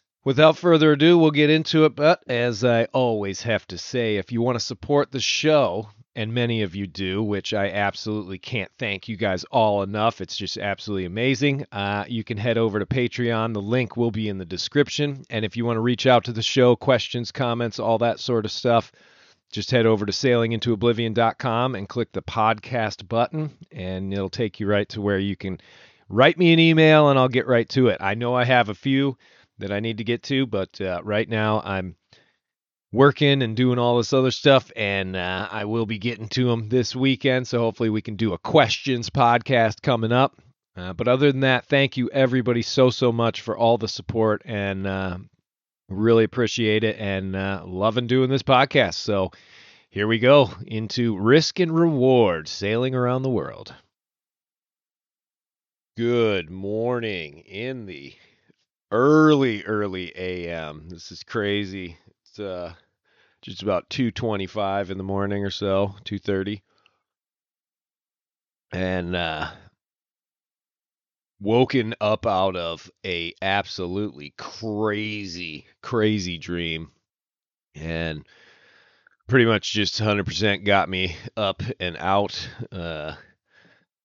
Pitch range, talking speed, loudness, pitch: 100-125 Hz, 165 wpm, -22 LUFS, 110 Hz